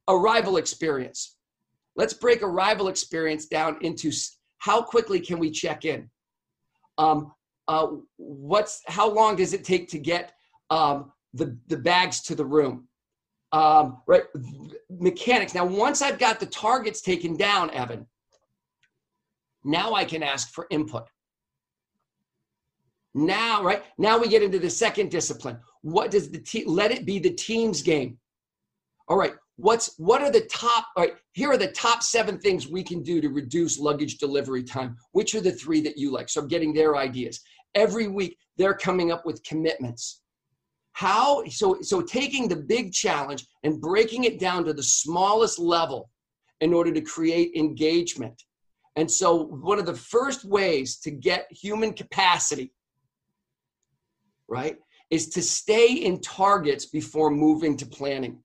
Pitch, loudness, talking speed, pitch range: 170 Hz, -24 LUFS, 155 wpm, 150-205 Hz